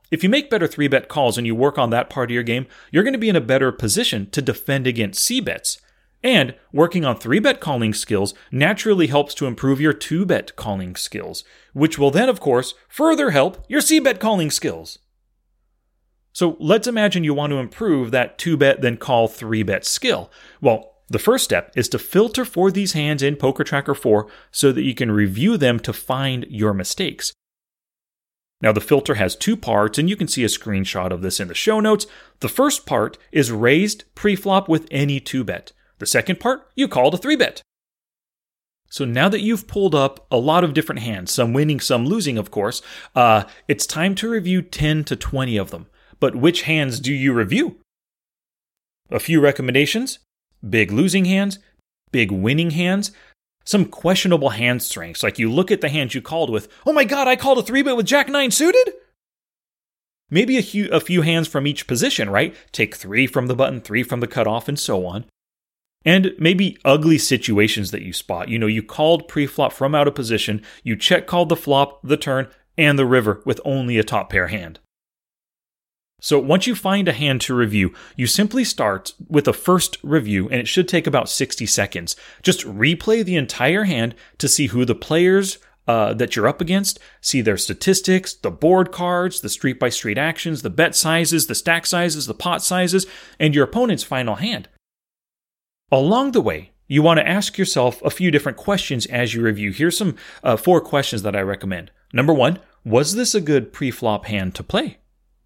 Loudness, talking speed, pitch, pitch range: -19 LUFS, 200 wpm, 145 Hz, 120-185 Hz